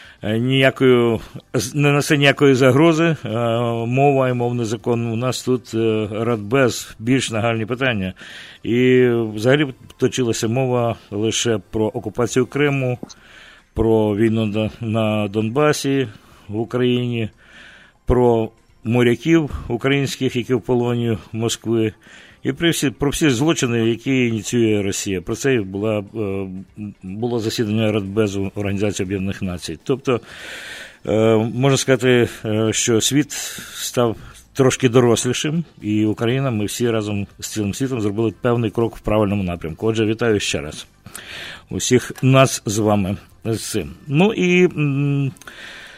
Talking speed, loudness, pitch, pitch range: 115 wpm, -19 LUFS, 115 Hz, 110-130 Hz